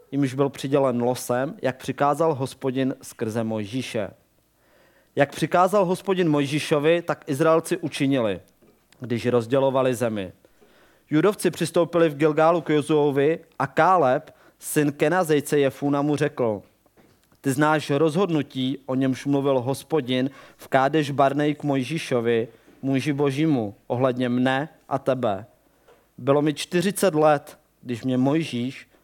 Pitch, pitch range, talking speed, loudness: 140 Hz, 130-155 Hz, 120 wpm, -23 LUFS